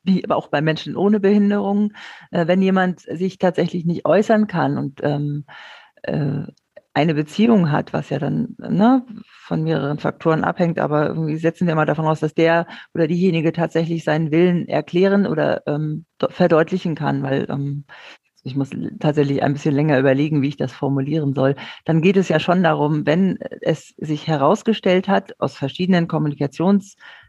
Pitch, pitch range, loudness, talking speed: 165 Hz, 150-190 Hz, -19 LUFS, 155 wpm